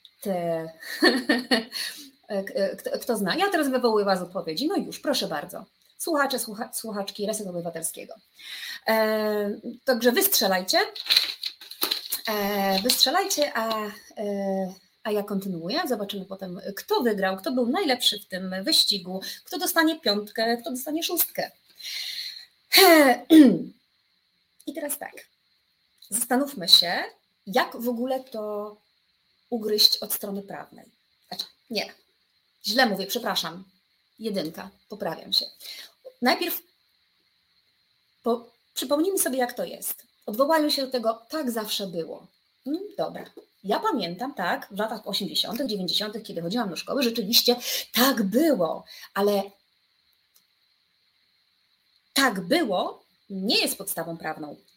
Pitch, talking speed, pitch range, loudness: 230 Hz, 110 wpm, 200-270 Hz, -24 LUFS